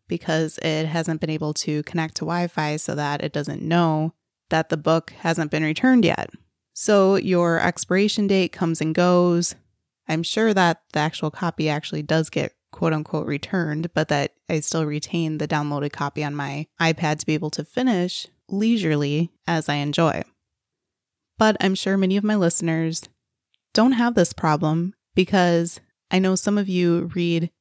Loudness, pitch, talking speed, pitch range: -22 LUFS, 165 Hz, 170 wpm, 155-180 Hz